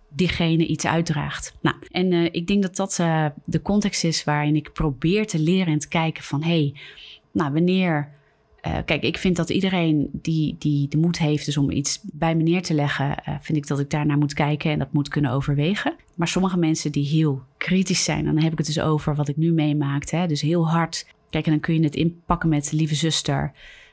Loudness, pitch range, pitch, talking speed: -22 LUFS, 150-170 Hz, 160 Hz, 225 wpm